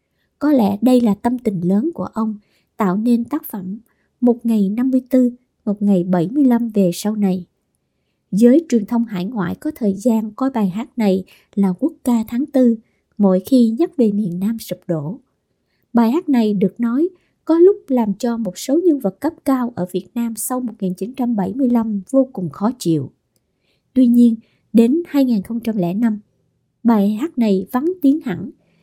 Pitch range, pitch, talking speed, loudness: 195-255 Hz, 230 Hz, 170 wpm, -18 LUFS